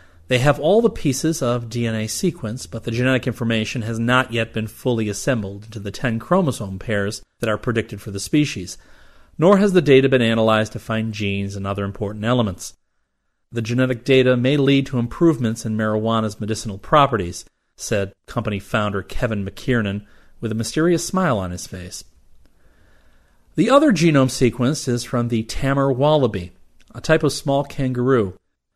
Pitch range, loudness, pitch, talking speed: 100-130 Hz, -20 LUFS, 115 Hz, 165 wpm